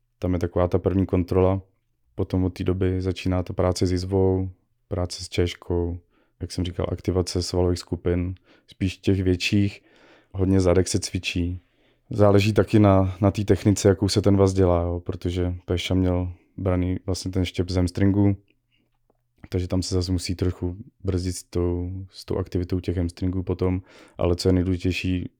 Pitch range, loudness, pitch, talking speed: 90-100 Hz, -24 LUFS, 95 Hz, 170 wpm